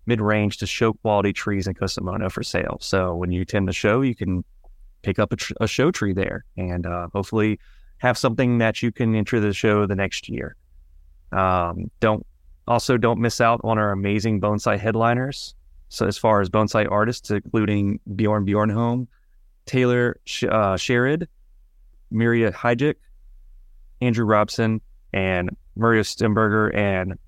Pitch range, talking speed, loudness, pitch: 95-115 Hz, 155 wpm, -22 LUFS, 105 Hz